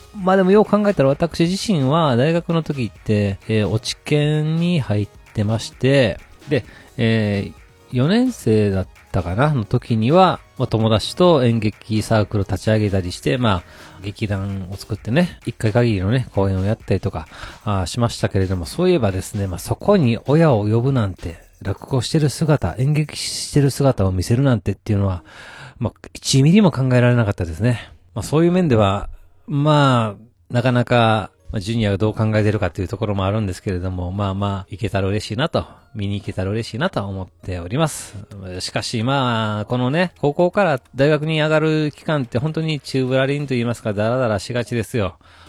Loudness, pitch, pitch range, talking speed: -19 LUFS, 110 Hz, 100-140 Hz, 370 characters per minute